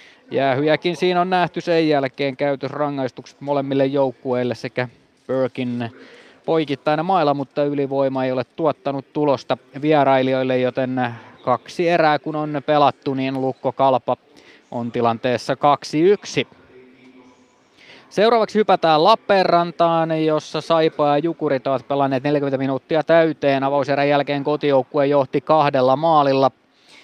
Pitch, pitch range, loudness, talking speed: 140 Hz, 130-155 Hz, -19 LUFS, 110 wpm